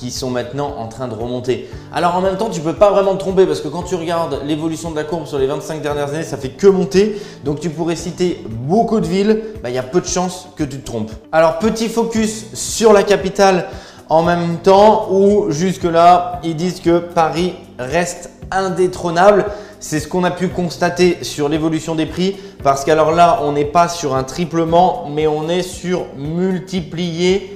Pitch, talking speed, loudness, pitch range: 175 Hz, 205 wpm, -16 LUFS, 155-190 Hz